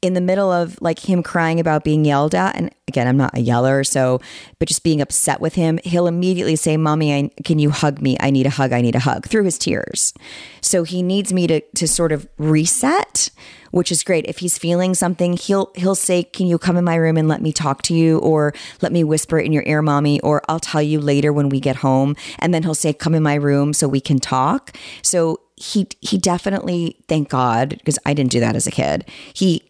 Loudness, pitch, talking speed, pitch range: -17 LUFS, 155 Hz, 240 wpm, 145-175 Hz